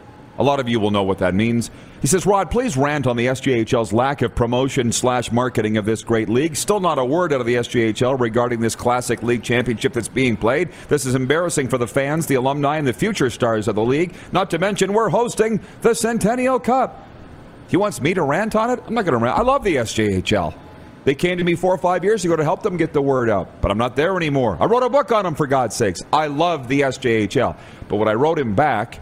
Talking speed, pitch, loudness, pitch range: 250 wpm, 135 Hz, -19 LUFS, 120-180 Hz